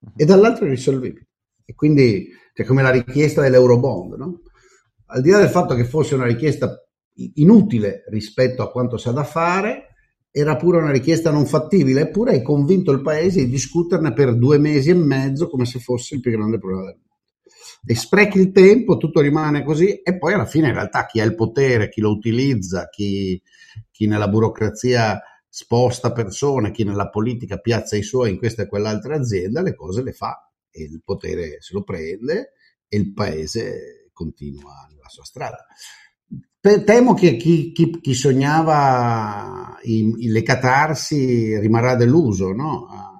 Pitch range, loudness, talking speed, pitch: 110-155 Hz, -17 LUFS, 170 wpm, 125 Hz